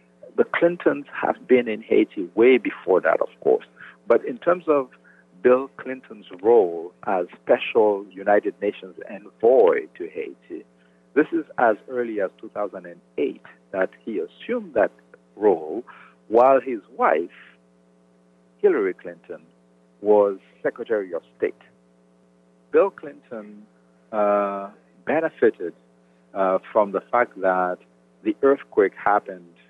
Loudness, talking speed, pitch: -22 LUFS, 115 wpm, 100 Hz